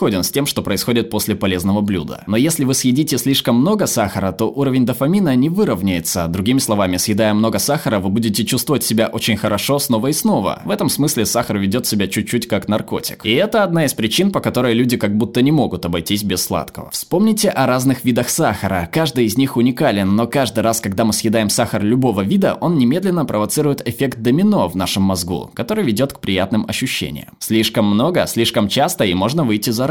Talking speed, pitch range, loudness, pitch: 195 wpm, 105-135 Hz, -16 LUFS, 115 Hz